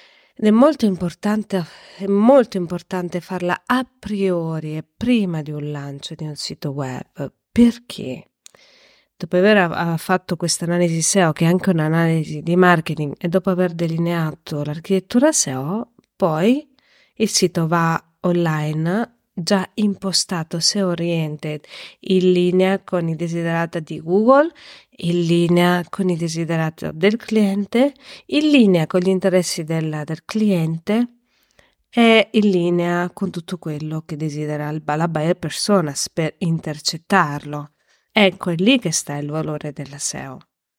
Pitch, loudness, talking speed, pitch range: 175 Hz, -19 LUFS, 135 wpm, 160-200 Hz